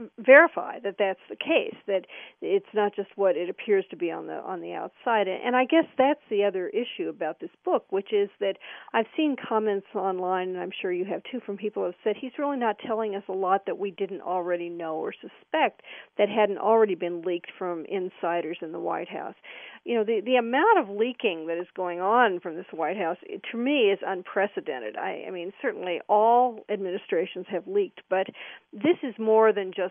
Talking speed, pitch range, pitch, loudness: 215 wpm, 185-245 Hz, 205 Hz, -26 LUFS